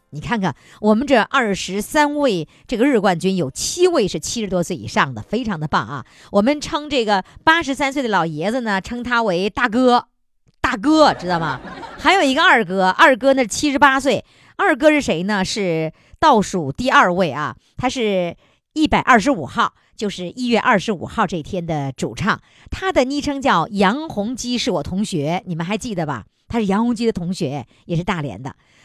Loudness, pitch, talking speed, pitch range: -18 LUFS, 210 Hz, 275 characters per minute, 175-260 Hz